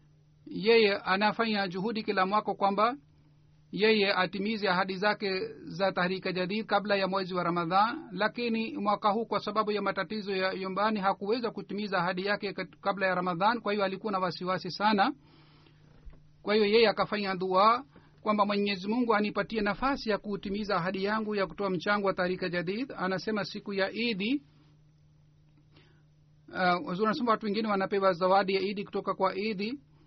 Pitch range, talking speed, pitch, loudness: 185-210 Hz, 130 wpm, 195 Hz, -29 LUFS